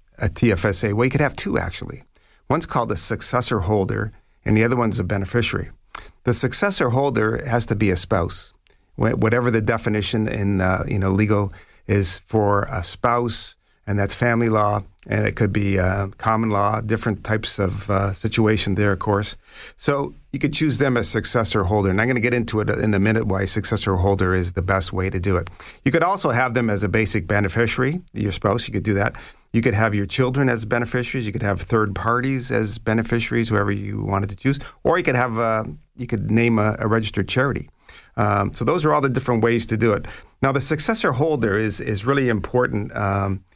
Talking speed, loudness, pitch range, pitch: 210 wpm, -20 LUFS, 100-120 Hz, 110 Hz